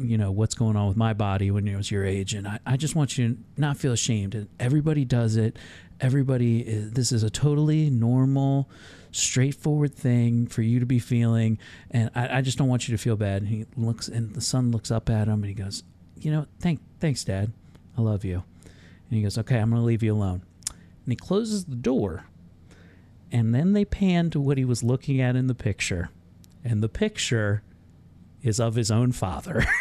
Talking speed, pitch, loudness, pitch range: 215 wpm, 115 Hz, -25 LUFS, 100-130 Hz